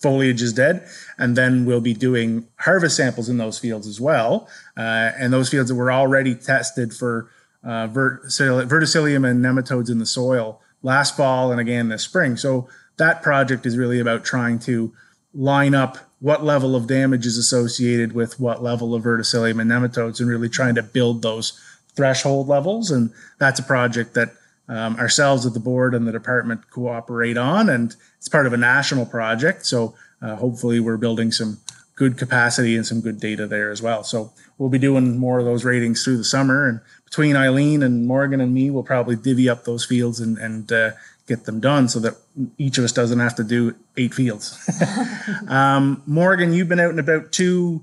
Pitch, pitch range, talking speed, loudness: 125 Hz, 115-135 Hz, 195 wpm, -19 LUFS